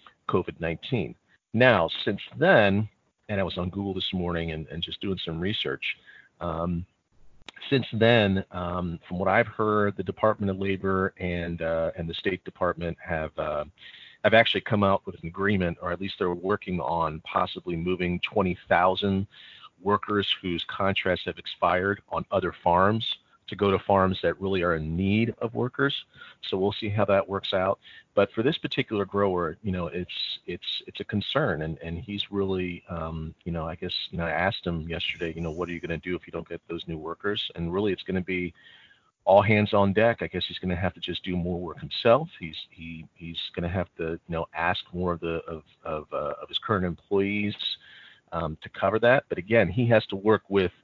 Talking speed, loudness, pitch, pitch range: 205 wpm, -27 LUFS, 90 Hz, 85-100 Hz